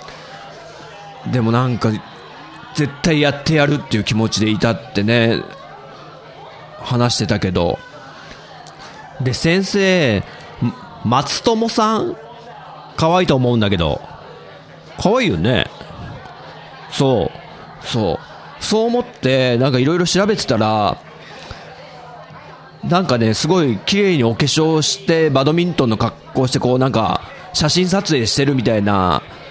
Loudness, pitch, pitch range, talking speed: -16 LUFS, 130 Hz, 115-170 Hz, 230 characters per minute